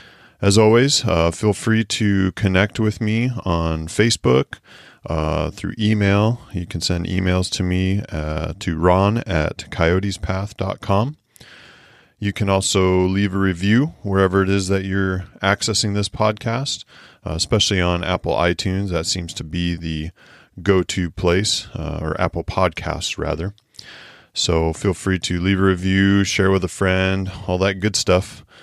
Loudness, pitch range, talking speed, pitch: -19 LUFS, 90-105 Hz, 150 wpm, 95 Hz